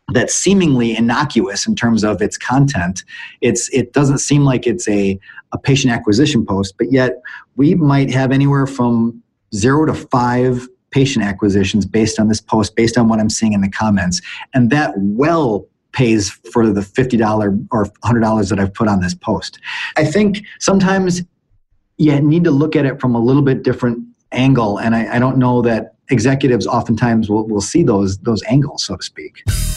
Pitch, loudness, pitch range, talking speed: 120 Hz, -15 LUFS, 110-135 Hz, 180 wpm